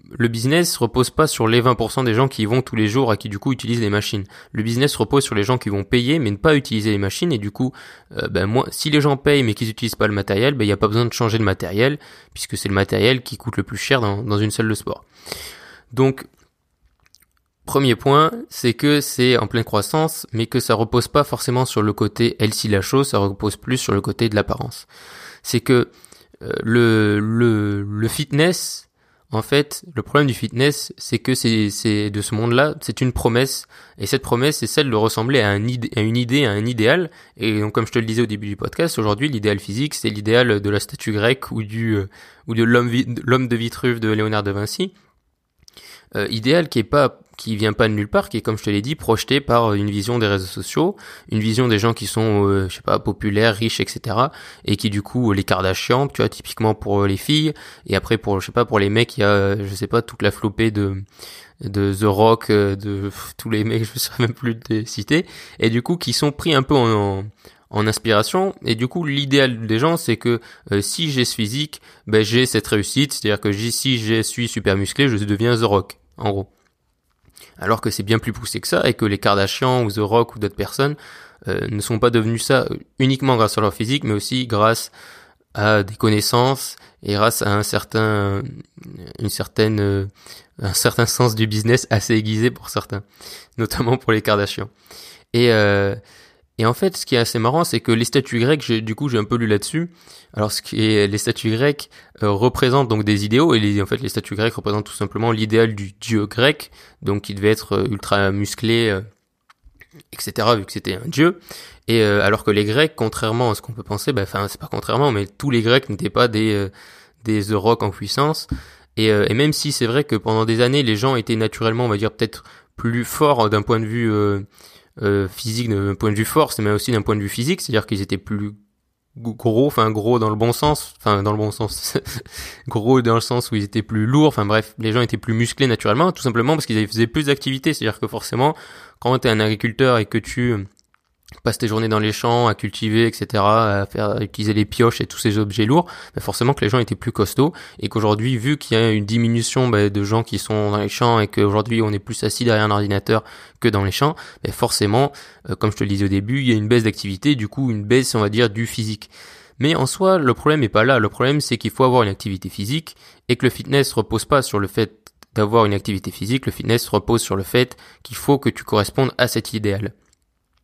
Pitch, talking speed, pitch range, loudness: 115 Hz, 235 wpm, 105-125 Hz, -19 LUFS